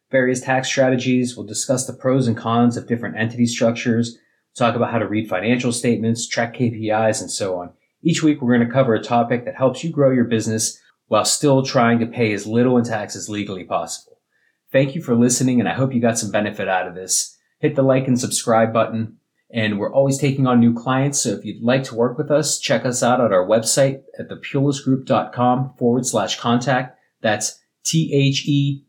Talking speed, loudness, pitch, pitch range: 210 wpm, -19 LUFS, 120 Hz, 115-135 Hz